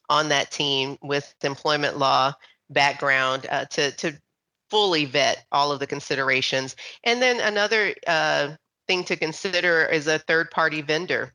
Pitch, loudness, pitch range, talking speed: 150 Hz, -22 LUFS, 140-170 Hz, 150 wpm